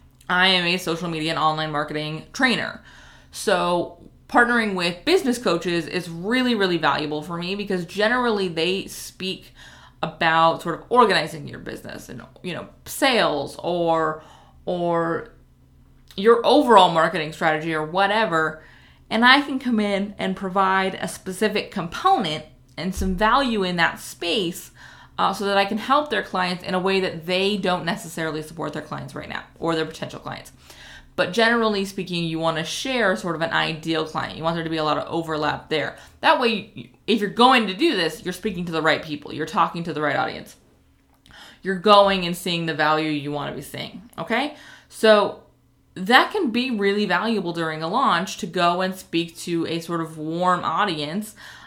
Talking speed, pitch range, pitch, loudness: 180 wpm, 160-205 Hz, 175 Hz, -21 LUFS